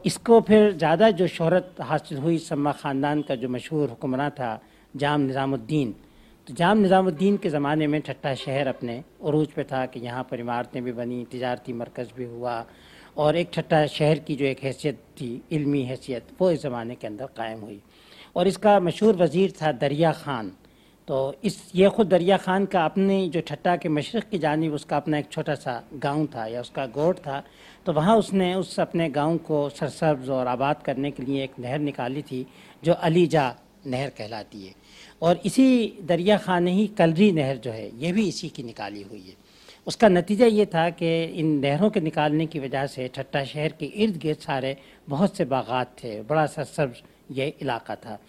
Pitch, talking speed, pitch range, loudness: 150 Hz, 190 wpm, 130-175 Hz, -24 LUFS